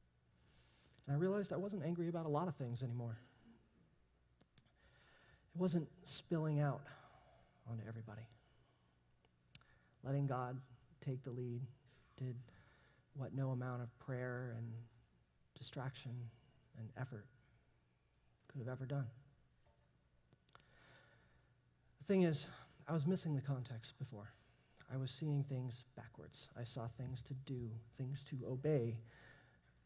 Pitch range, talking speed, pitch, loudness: 115-140 Hz, 120 wpm, 125 Hz, -44 LUFS